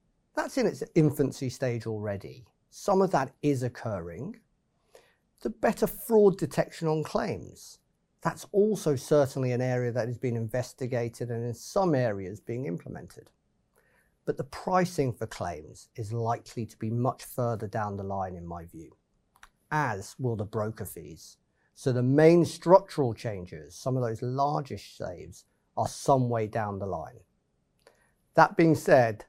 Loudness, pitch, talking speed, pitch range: -28 LUFS, 125 Hz, 150 wpm, 110-155 Hz